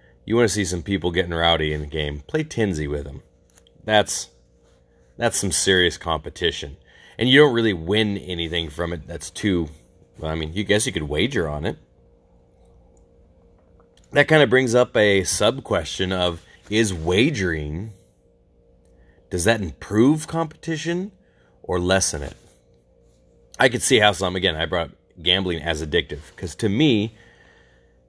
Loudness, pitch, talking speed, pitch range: -21 LUFS, 90 Hz, 150 wpm, 80-105 Hz